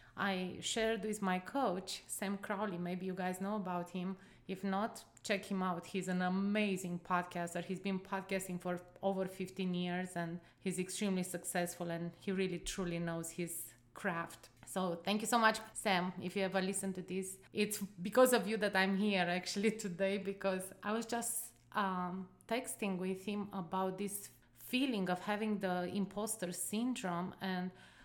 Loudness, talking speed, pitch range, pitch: -38 LUFS, 165 wpm, 180-205 Hz, 190 Hz